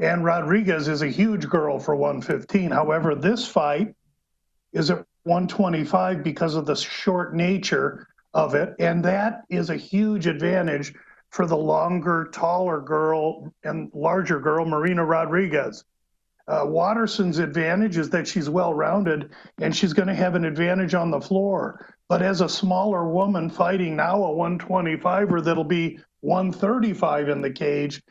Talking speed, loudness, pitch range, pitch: 150 wpm, -23 LUFS, 160-190 Hz, 175 Hz